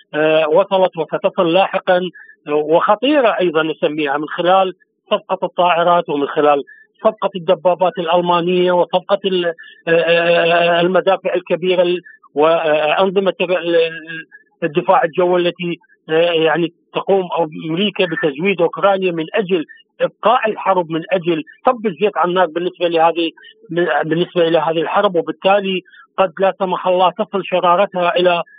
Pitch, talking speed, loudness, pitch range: 180 Hz, 105 wpm, -16 LUFS, 165-190 Hz